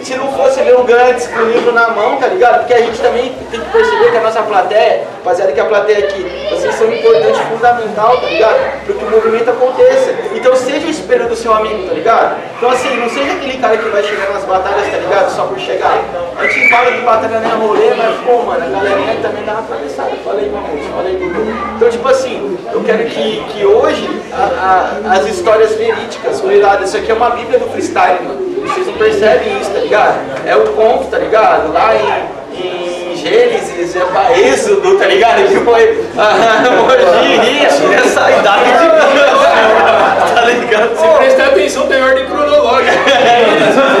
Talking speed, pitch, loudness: 205 wpm, 245 Hz, -10 LUFS